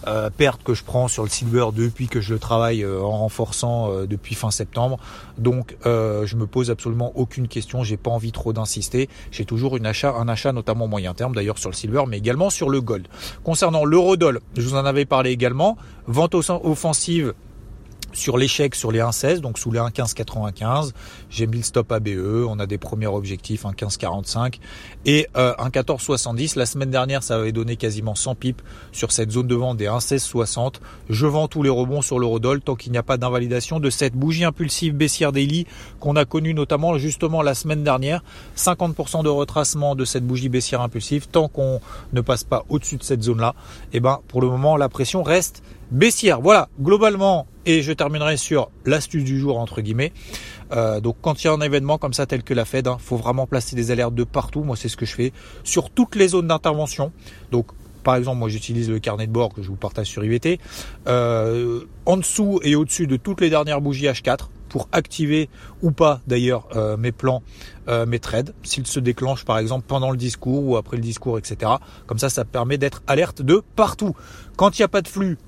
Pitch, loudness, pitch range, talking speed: 125 Hz, -21 LUFS, 115-145 Hz, 210 wpm